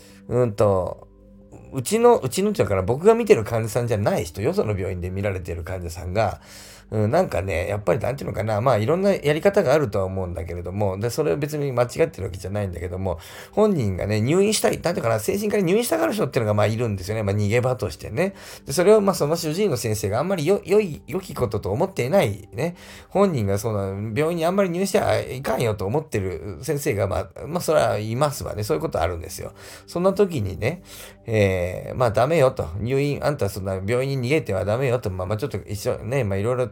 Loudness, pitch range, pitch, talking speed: -23 LUFS, 100-155 Hz, 115 Hz, 480 characters per minute